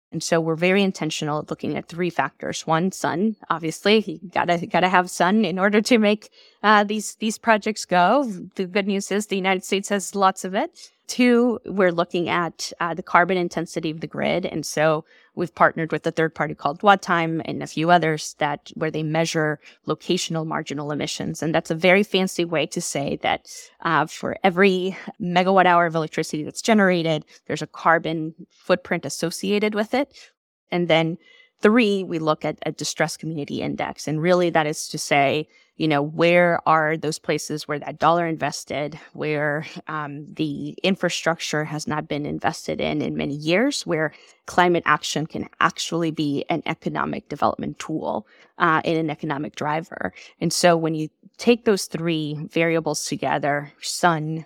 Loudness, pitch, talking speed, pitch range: -22 LUFS, 170 Hz, 175 wpm, 155-190 Hz